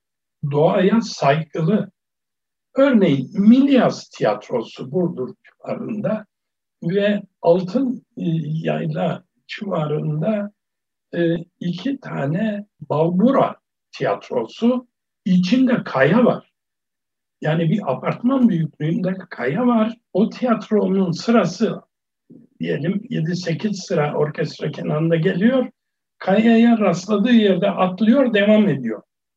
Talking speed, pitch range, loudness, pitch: 80 wpm, 165-225 Hz, -19 LUFS, 195 Hz